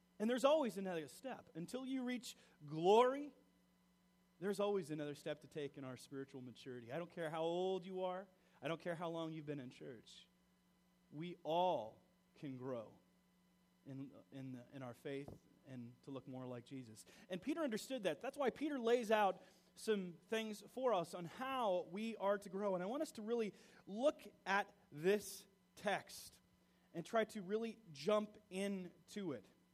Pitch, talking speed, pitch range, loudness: 180 Hz, 175 wpm, 140-210 Hz, -43 LUFS